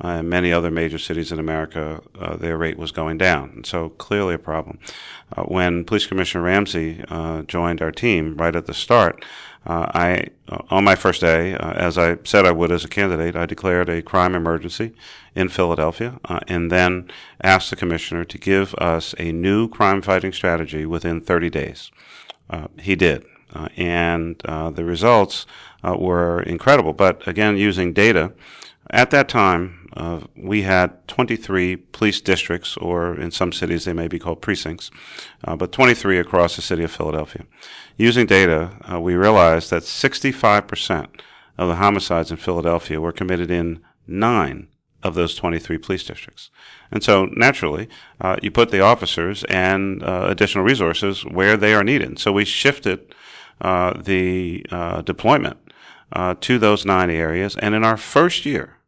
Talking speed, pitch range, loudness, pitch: 170 wpm, 85-95 Hz, -19 LUFS, 90 Hz